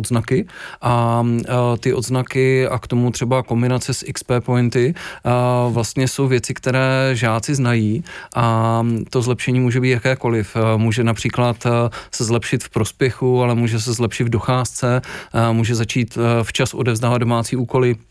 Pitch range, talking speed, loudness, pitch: 115-130 Hz, 145 wpm, -18 LUFS, 120 Hz